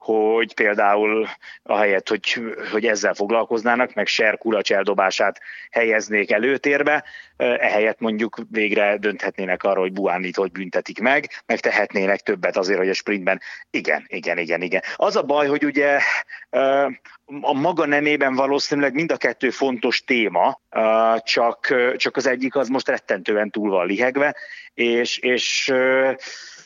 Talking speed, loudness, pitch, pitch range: 135 wpm, -20 LUFS, 115 Hz, 105-135 Hz